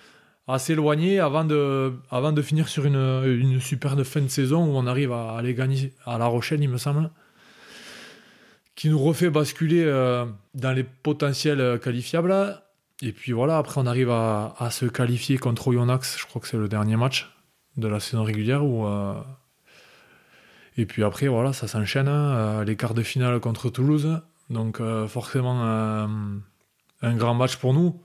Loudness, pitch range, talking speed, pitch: -24 LUFS, 120-150 Hz, 165 wpm, 130 Hz